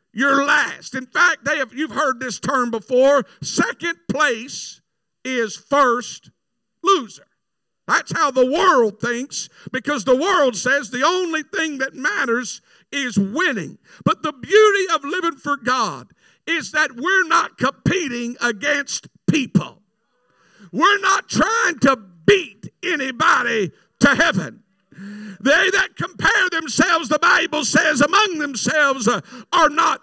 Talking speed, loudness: 130 wpm, -18 LUFS